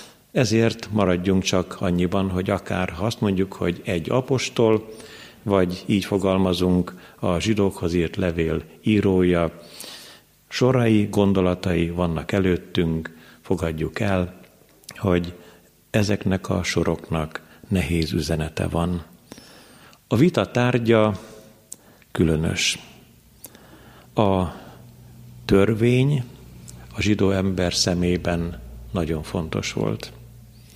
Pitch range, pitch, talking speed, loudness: 85-110 Hz, 95 Hz, 90 wpm, -22 LUFS